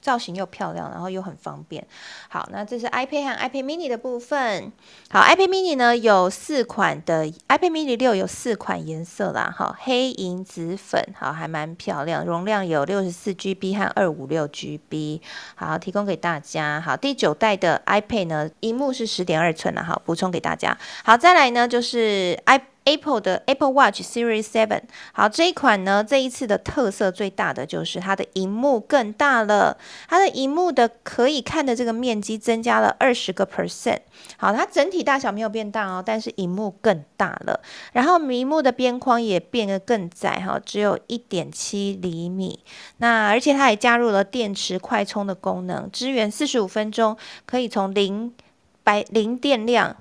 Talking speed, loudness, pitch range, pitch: 320 characters per minute, -21 LUFS, 190-250 Hz, 220 Hz